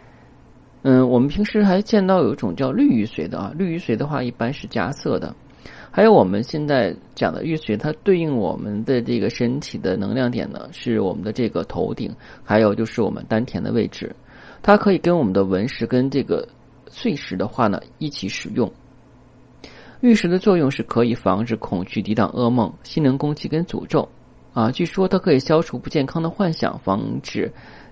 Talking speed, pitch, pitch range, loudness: 285 characters per minute, 140 Hz, 115-175 Hz, -20 LUFS